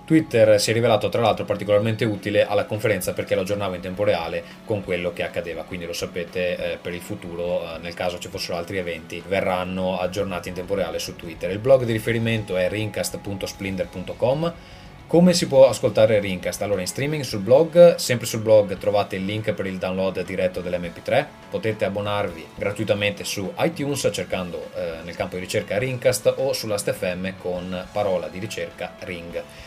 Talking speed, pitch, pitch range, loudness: 175 wpm, 100 Hz, 90-135 Hz, -23 LUFS